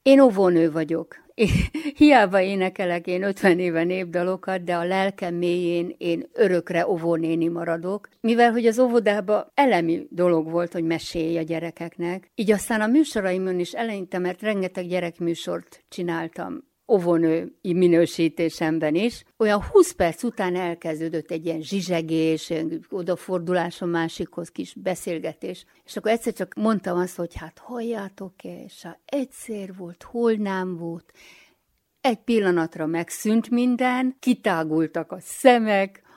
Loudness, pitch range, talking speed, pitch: -23 LUFS, 170-215 Hz, 130 wpm, 180 Hz